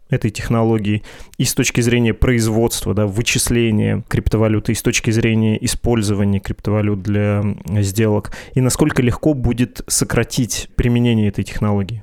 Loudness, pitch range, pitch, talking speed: -17 LUFS, 105-120 Hz, 115 Hz, 130 wpm